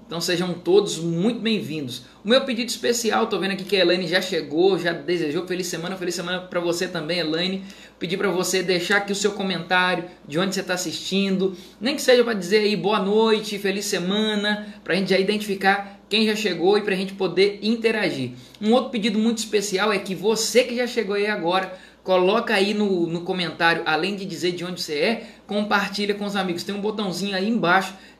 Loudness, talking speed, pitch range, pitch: -22 LUFS, 205 wpm, 180-210 Hz, 195 Hz